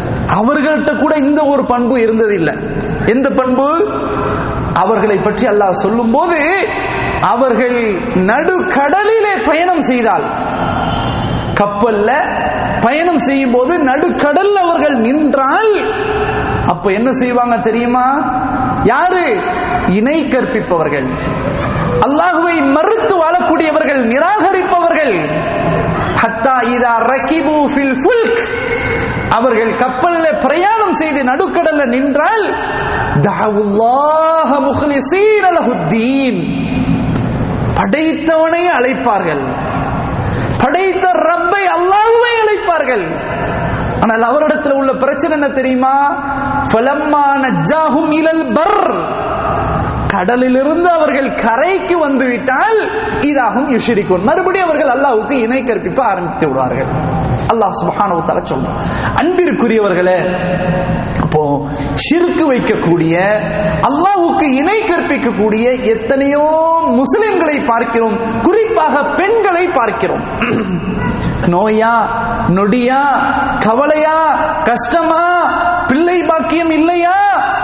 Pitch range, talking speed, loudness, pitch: 240-345 Hz, 75 wpm, -12 LUFS, 285 Hz